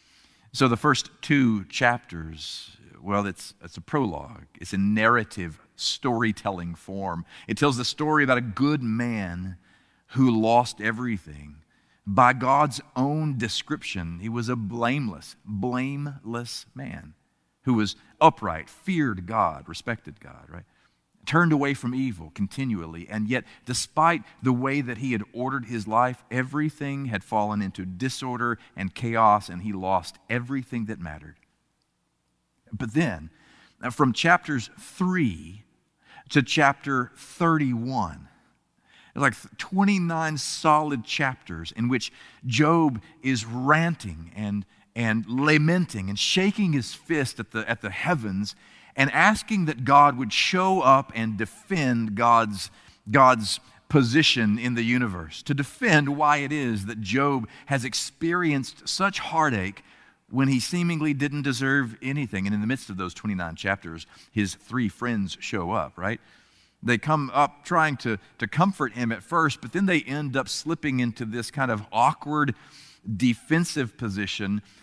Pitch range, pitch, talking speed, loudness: 105-145 Hz, 120 Hz, 135 wpm, -25 LUFS